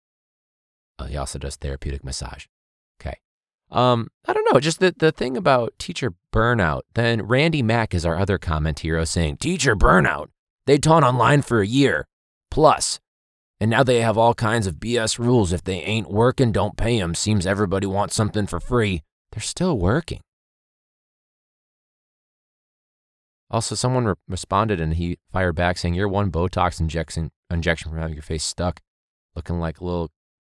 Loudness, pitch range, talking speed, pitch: -21 LUFS, 80-115 Hz, 165 wpm, 95 Hz